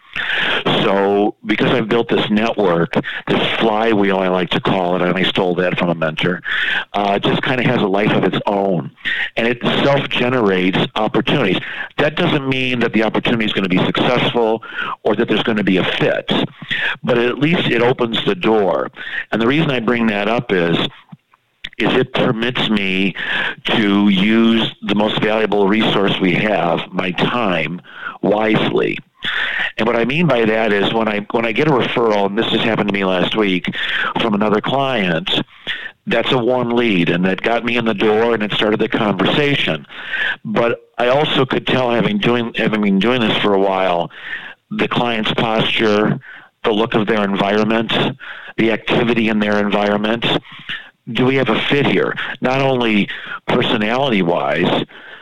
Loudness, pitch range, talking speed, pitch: -16 LUFS, 100-120 Hz, 175 wpm, 110 Hz